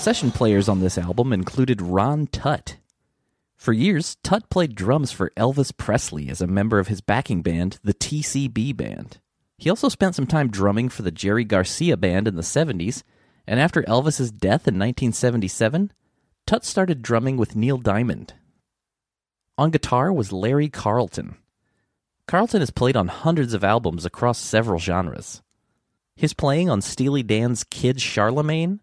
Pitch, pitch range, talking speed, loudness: 120 Hz, 100-145 Hz, 155 wpm, -22 LUFS